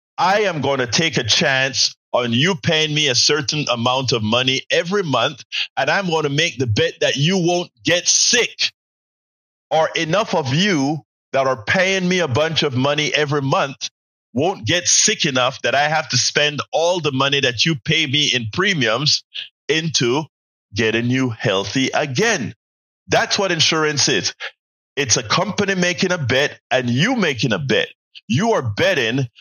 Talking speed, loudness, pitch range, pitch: 175 wpm, -17 LUFS, 125-165 Hz, 145 Hz